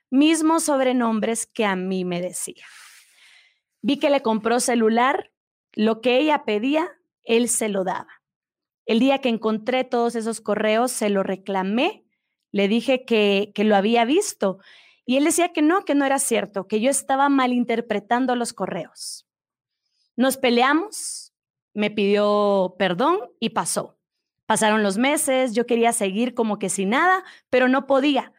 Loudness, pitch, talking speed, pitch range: -21 LUFS, 235 Hz, 150 wpm, 210-270 Hz